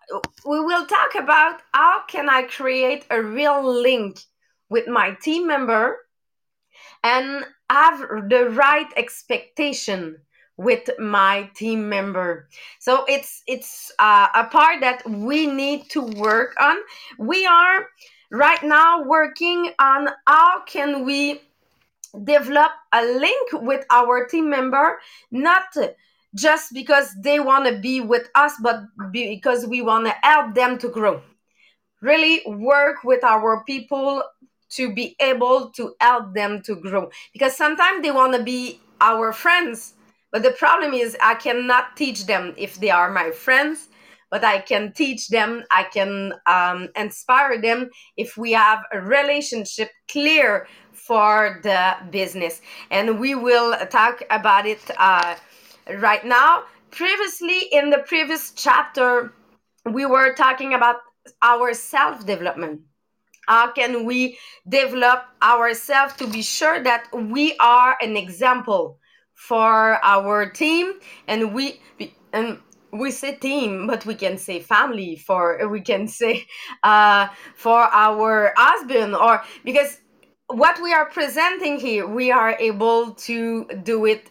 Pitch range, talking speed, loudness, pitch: 220-290 Hz, 135 wpm, -18 LUFS, 250 Hz